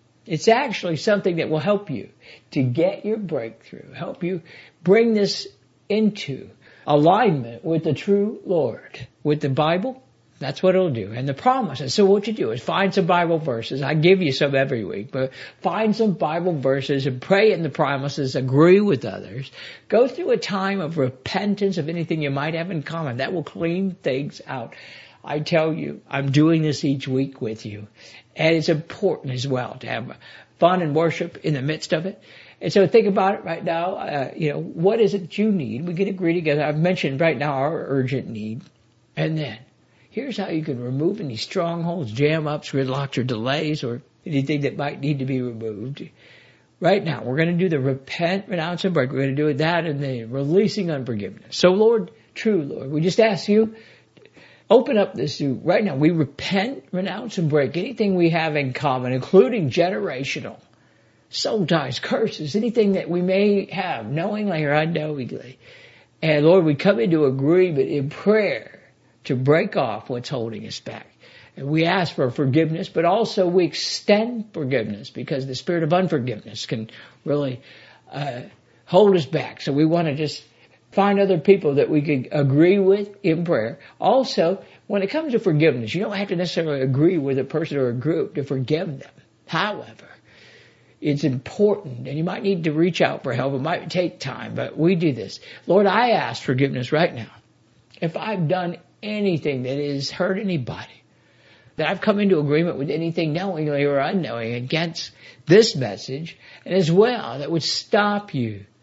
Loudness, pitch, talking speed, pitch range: -21 LUFS, 160 Hz, 185 wpm, 135-190 Hz